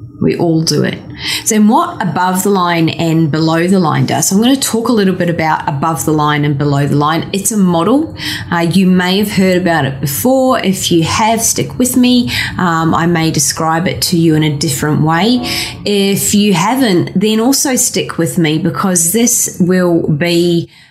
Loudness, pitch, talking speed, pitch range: -12 LUFS, 170 Hz, 200 wpm, 160-205 Hz